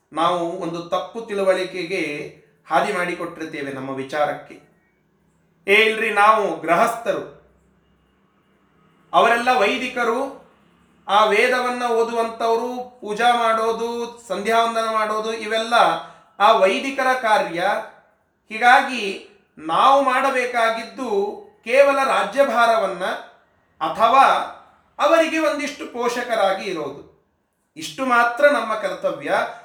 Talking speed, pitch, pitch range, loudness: 80 wpm, 225 Hz, 185-250 Hz, -19 LUFS